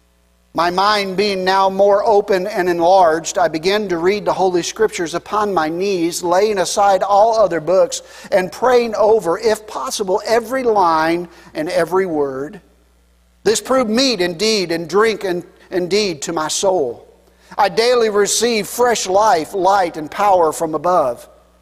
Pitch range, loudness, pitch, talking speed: 165-210 Hz, -16 LUFS, 190 Hz, 145 wpm